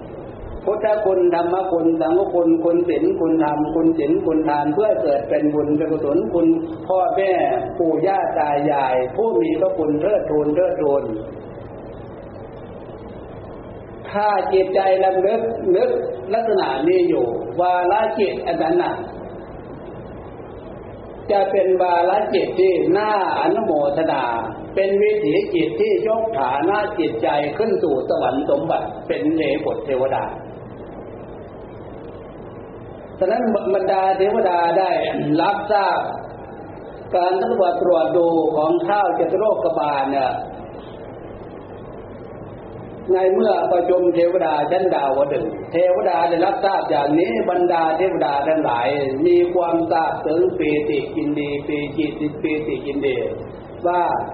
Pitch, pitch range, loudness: 180 Hz, 150-205 Hz, -19 LUFS